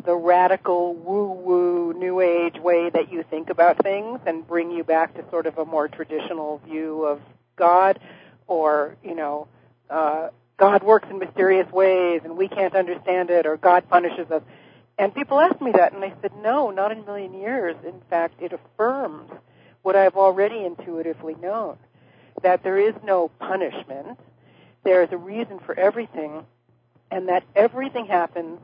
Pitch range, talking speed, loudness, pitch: 165-195 Hz, 170 wpm, -21 LUFS, 180 Hz